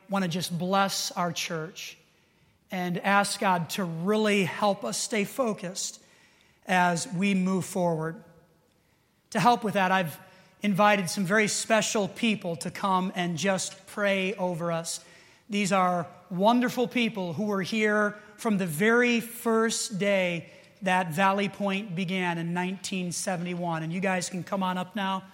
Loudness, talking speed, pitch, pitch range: -27 LUFS, 145 wpm, 190 Hz, 180-205 Hz